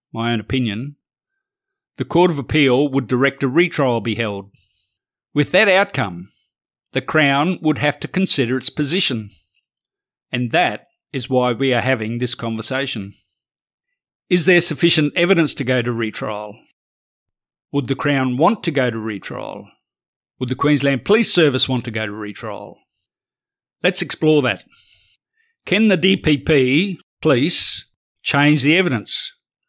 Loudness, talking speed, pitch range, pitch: -18 LUFS, 140 wpm, 120-170 Hz, 140 Hz